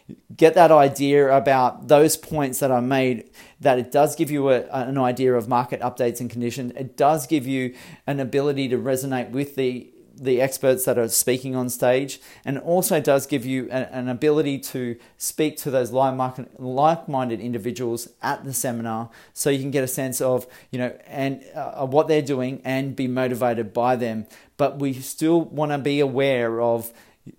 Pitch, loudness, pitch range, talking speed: 130 Hz, -22 LUFS, 125-140 Hz, 190 wpm